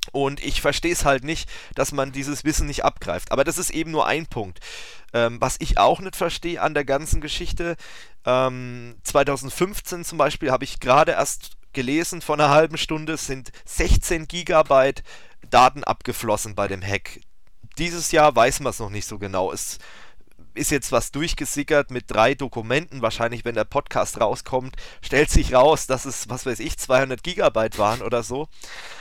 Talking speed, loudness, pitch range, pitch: 175 wpm, -22 LUFS, 120-155 Hz, 135 Hz